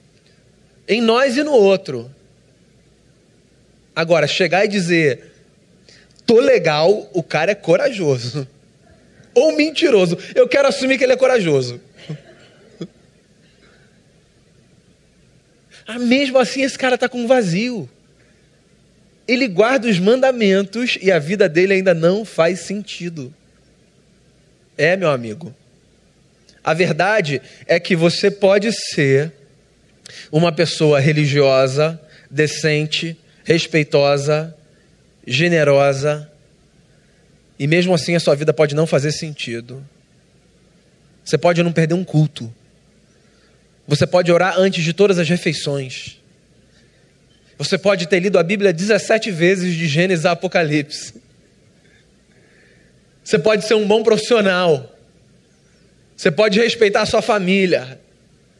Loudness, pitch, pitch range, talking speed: -16 LUFS, 175 Hz, 150-205 Hz, 110 wpm